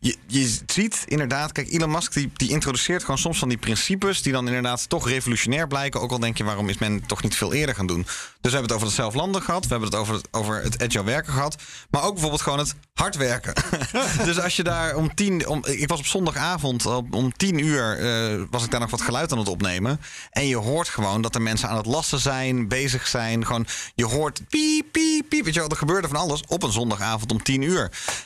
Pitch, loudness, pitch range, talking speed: 130 Hz, -23 LUFS, 115-155 Hz, 245 wpm